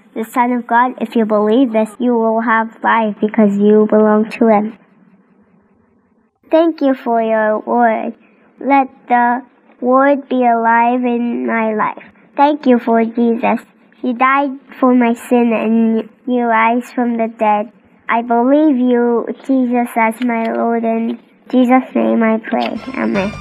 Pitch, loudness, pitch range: 230 Hz, -14 LUFS, 220-245 Hz